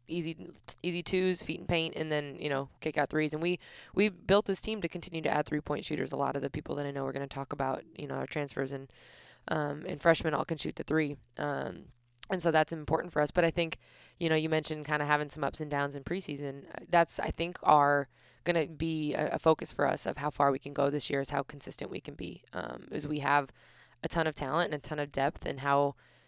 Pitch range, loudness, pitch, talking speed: 140-165 Hz, -32 LUFS, 150 Hz, 260 wpm